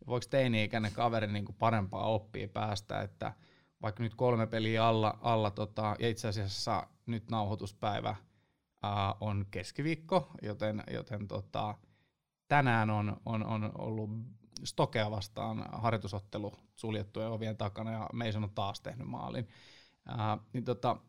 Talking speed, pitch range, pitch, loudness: 130 wpm, 105-115 Hz, 110 Hz, -35 LUFS